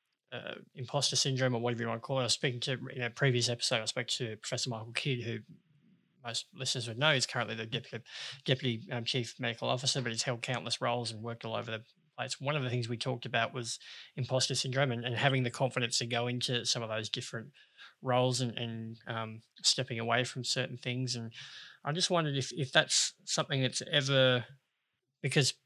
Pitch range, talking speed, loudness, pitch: 120-135 Hz, 215 wpm, -32 LUFS, 125 Hz